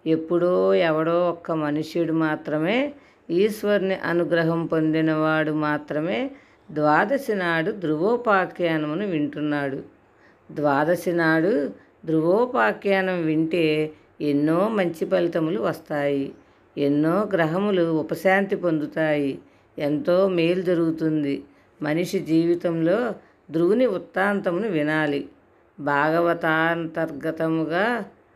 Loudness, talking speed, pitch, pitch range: -23 LUFS, 70 wpm, 165 Hz, 155-180 Hz